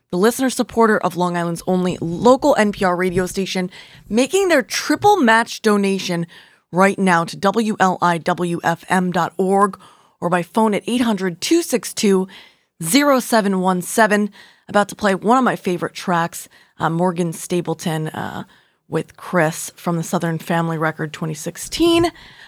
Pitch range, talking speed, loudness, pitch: 170-225 Hz, 125 wpm, -18 LUFS, 185 Hz